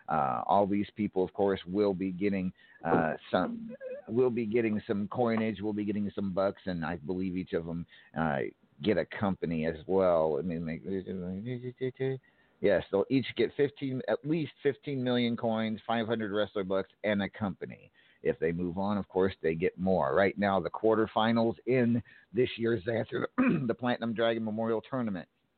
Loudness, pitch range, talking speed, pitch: -31 LUFS, 95-120 Hz, 180 wpm, 110 Hz